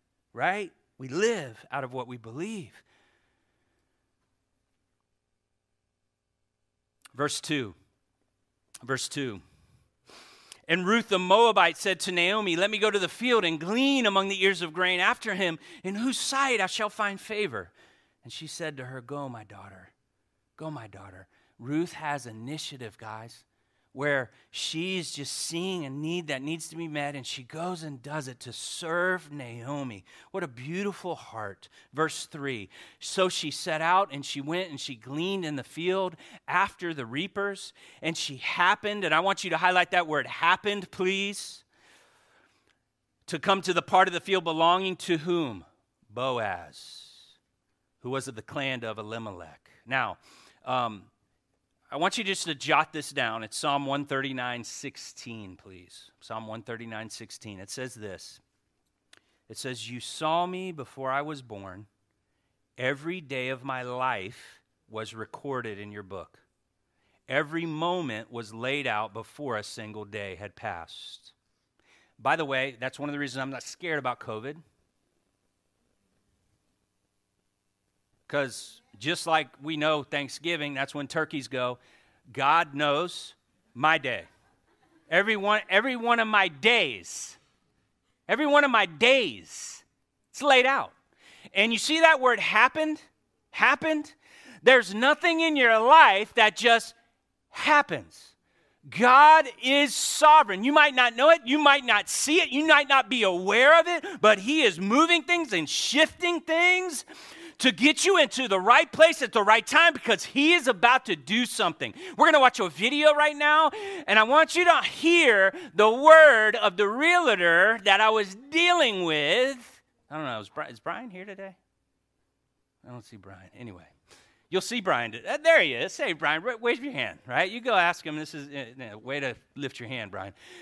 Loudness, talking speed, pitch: -24 LUFS, 160 wpm, 165 Hz